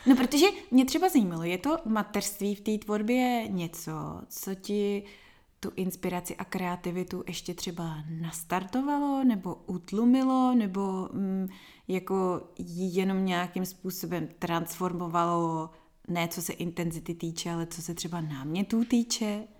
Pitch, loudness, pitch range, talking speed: 185 Hz, -30 LUFS, 175-215 Hz, 125 wpm